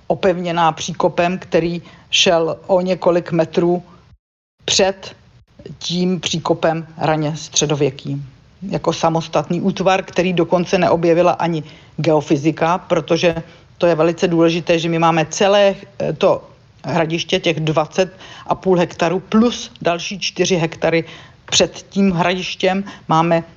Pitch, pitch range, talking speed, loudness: 170 Hz, 160-180 Hz, 105 wpm, -17 LUFS